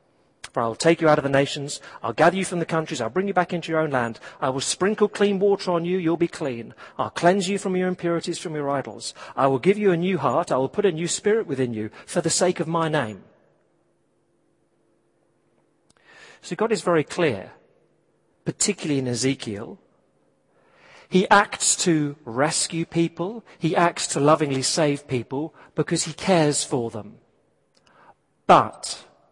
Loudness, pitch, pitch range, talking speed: -23 LUFS, 165 Hz, 135-185 Hz, 190 wpm